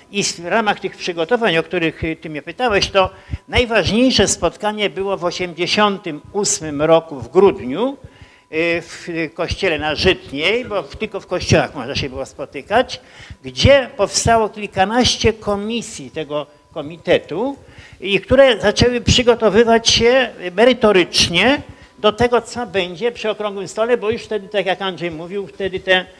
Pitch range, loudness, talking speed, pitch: 170-220 Hz, -17 LUFS, 135 wpm, 195 Hz